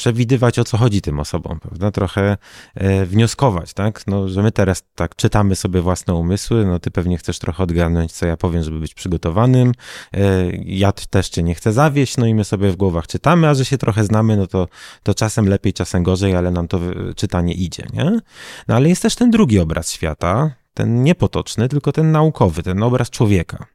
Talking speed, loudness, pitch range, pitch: 200 wpm, -17 LUFS, 90-120 Hz, 100 Hz